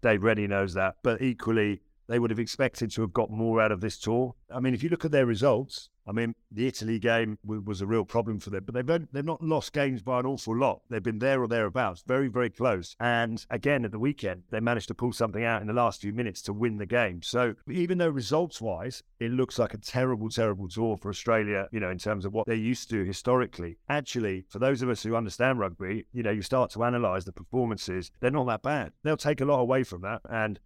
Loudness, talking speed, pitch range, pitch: -29 LUFS, 250 wpm, 105-125 Hz, 115 Hz